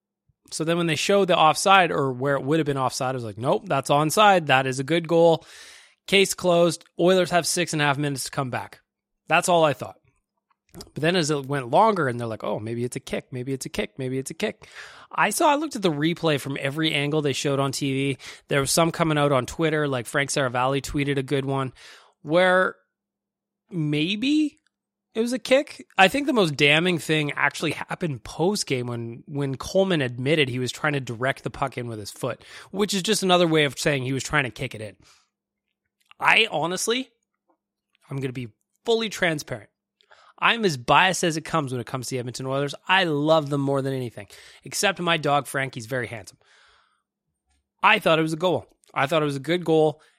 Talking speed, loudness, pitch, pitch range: 215 wpm, -23 LUFS, 150 Hz, 135-175 Hz